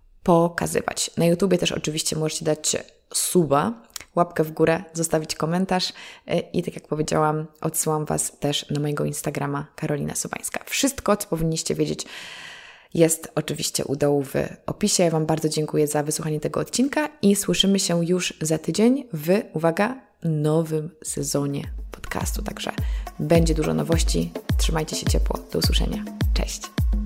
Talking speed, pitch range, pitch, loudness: 140 wpm, 155-185 Hz, 160 Hz, -23 LUFS